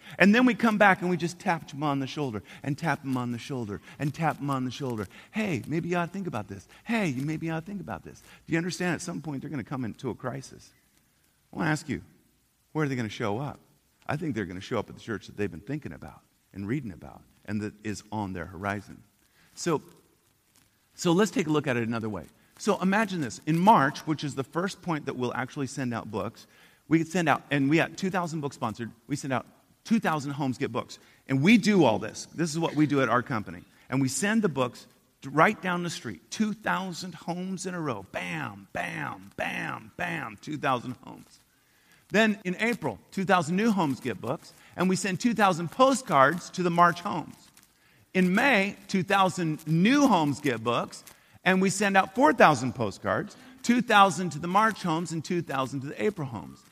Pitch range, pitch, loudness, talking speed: 130-185 Hz, 155 Hz, -27 LUFS, 220 wpm